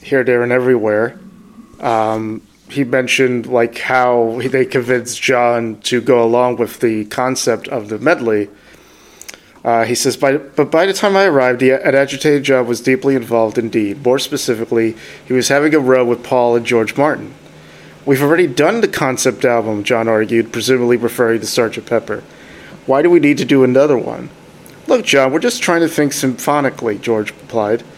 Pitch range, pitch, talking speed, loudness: 115-140 Hz, 125 Hz, 170 wpm, -14 LUFS